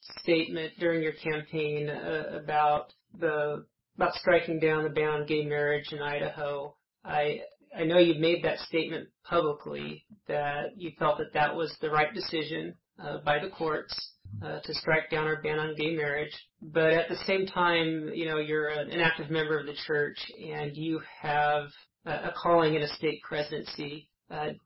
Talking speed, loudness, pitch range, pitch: 175 wpm, -30 LUFS, 150-160 Hz, 155 Hz